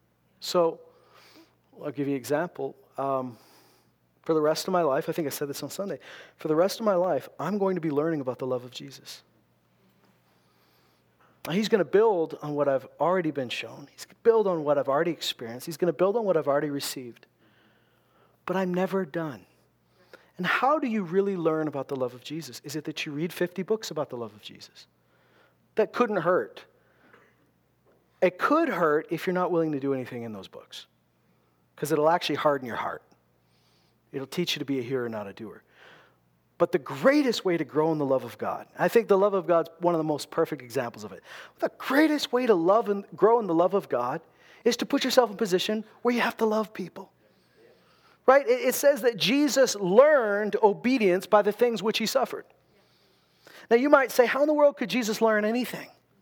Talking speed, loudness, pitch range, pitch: 215 wpm, -26 LUFS, 135-215 Hz, 170 Hz